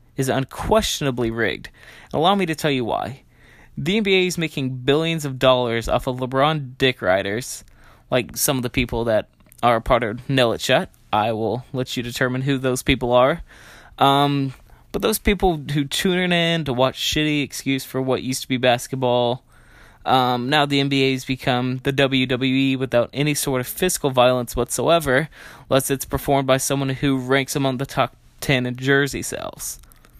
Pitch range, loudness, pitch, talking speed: 125-145 Hz, -20 LUFS, 135 Hz, 180 wpm